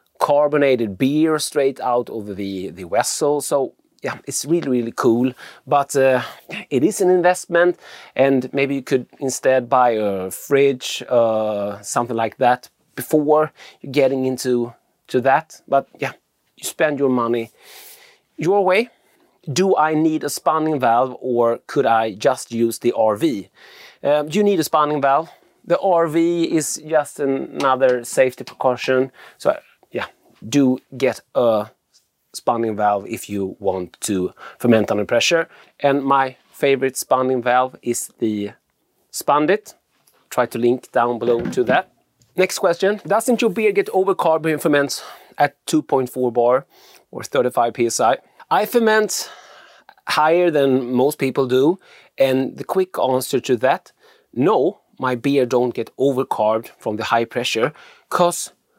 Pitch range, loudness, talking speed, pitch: 120-155 Hz, -19 LUFS, 145 wpm, 135 Hz